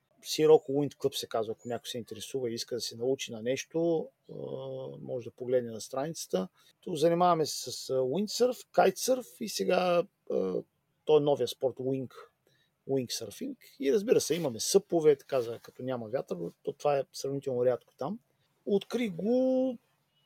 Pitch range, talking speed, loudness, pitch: 130-200 Hz, 155 wpm, -31 LUFS, 155 Hz